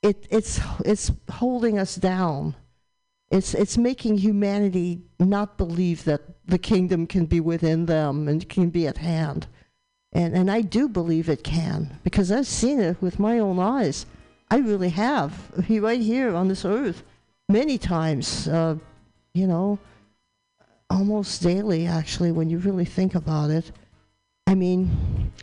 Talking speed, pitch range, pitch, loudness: 150 wpm, 165-205 Hz, 180 Hz, -23 LUFS